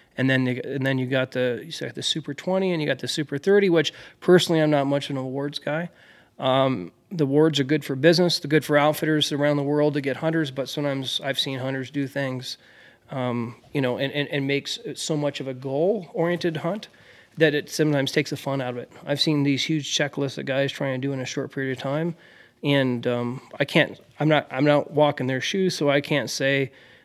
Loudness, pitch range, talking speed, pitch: -24 LUFS, 135-155 Hz, 240 wpm, 140 Hz